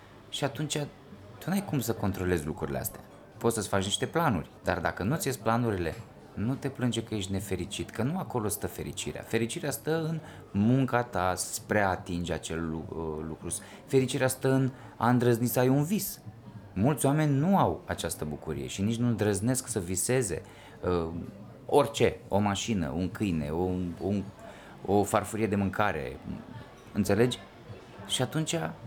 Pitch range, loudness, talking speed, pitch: 95-130 Hz, -30 LUFS, 160 wpm, 110 Hz